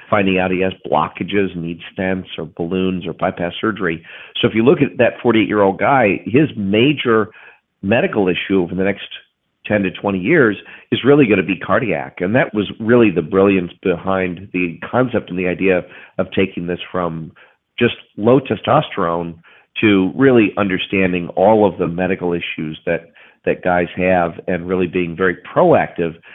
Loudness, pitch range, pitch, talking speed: -17 LUFS, 90-105 Hz, 95 Hz, 170 wpm